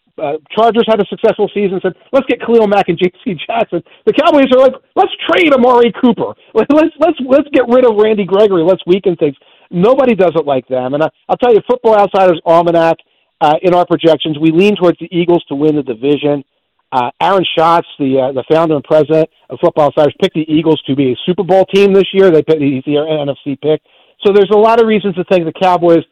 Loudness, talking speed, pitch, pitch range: -11 LUFS, 225 wpm, 180 Hz, 155-220 Hz